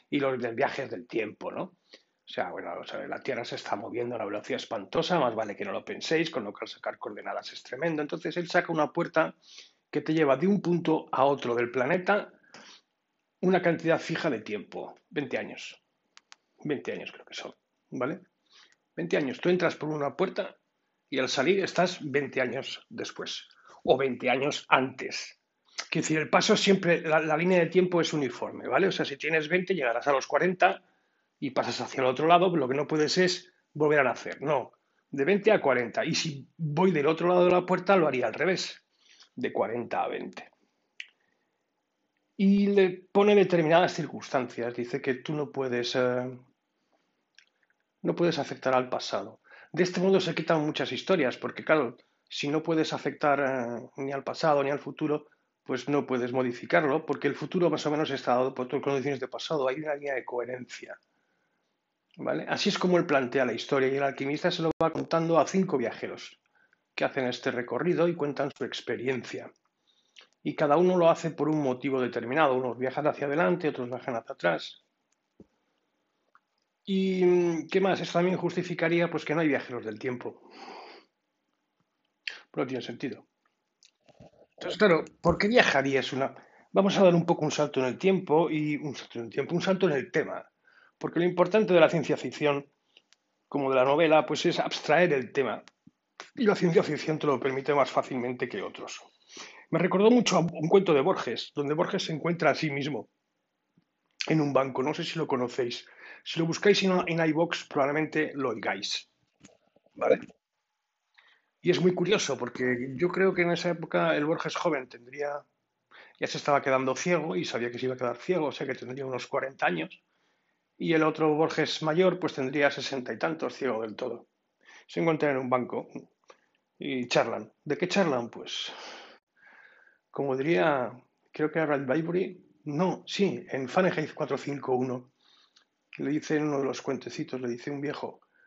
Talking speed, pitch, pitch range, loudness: 185 wpm, 155 Hz, 135-175 Hz, -28 LUFS